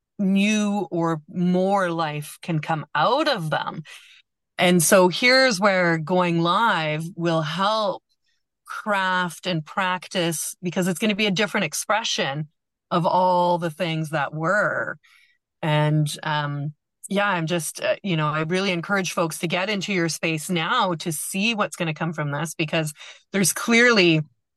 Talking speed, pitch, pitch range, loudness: 155 wpm, 175 Hz, 160-195 Hz, -22 LUFS